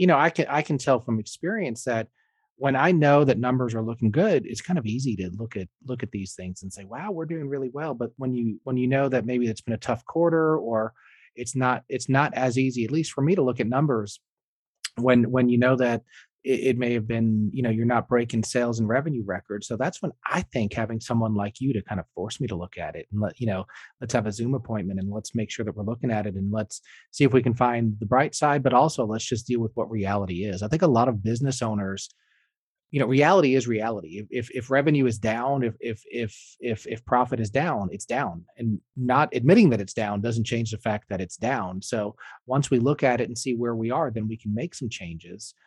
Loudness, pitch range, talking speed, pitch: -25 LUFS, 110-130 Hz, 255 wpm, 120 Hz